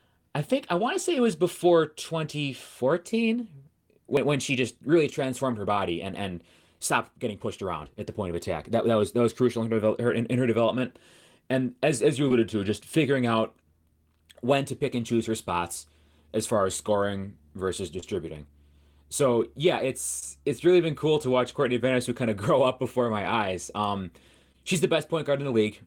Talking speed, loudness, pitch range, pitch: 210 wpm, -27 LUFS, 100-145 Hz, 120 Hz